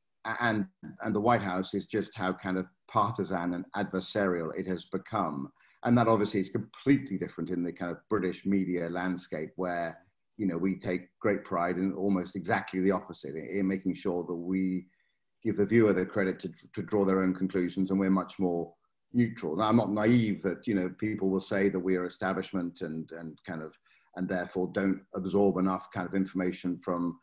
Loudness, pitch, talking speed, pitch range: -31 LUFS, 95 Hz, 200 wpm, 90-100 Hz